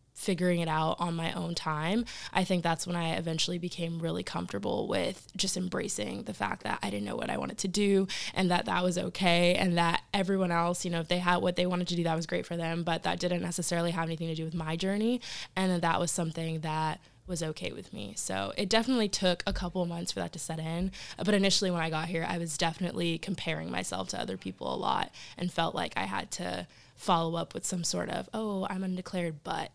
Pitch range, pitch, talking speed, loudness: 165-185 Hz, 175 Hz, 240 wpm, -31 LUFS